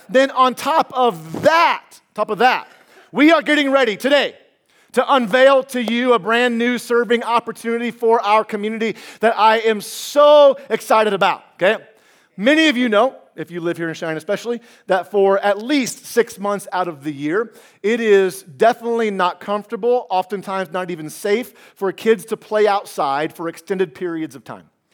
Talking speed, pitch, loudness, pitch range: 175 wpm, 225 Hz, -17 LUFS, 195-245 Hz